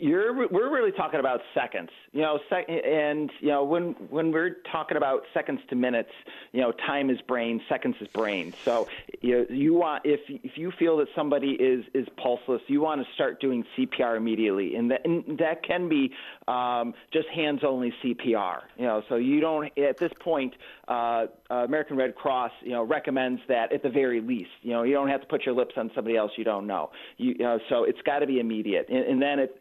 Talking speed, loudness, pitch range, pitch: 215 wpm, -27 LUFS, 120-160 Hz, 140 Hz